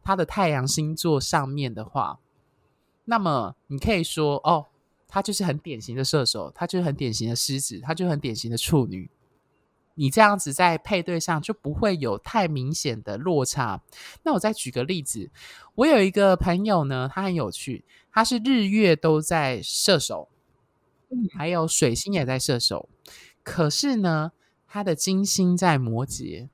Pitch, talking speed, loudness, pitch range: 160 Hz, 235 characters per minute, -24 LUFS, 135-190 Hz